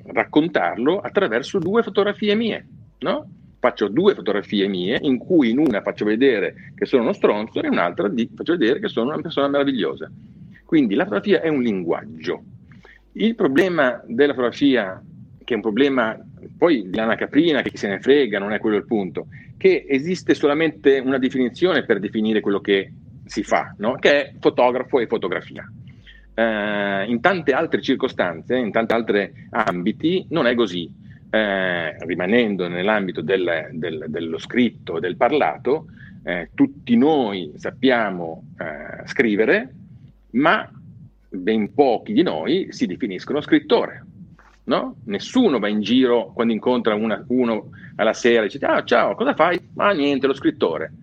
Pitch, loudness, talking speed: 135 Hz, -20 LUFS, 160 wpm